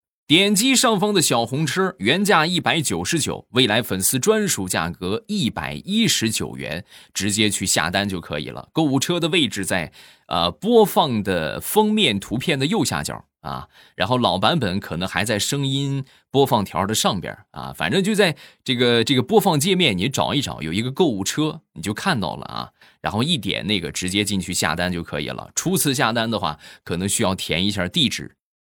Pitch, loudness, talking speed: 125 Hz, -20 LUFS, 285 characters per minute